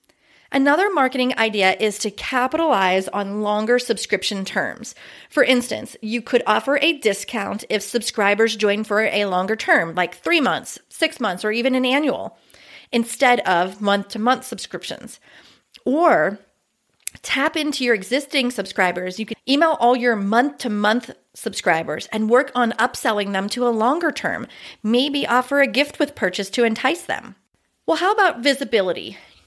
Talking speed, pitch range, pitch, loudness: 145 wpm, 205-265 Hz, 235 Hz, -20 LUFS